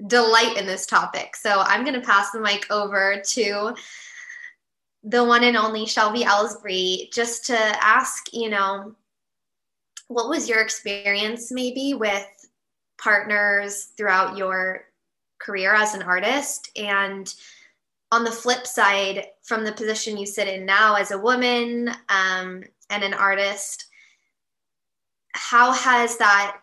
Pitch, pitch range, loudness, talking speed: 210 Hz, 200-235 Hz, -21 LUFS, 135 wpm